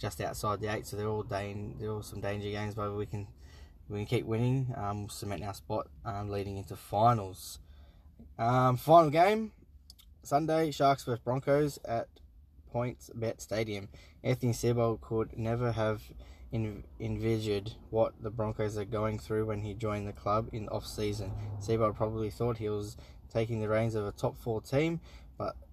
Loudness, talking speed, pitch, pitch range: -33 LUFS, 175 wpm, 110 Hz, 100-115 Hz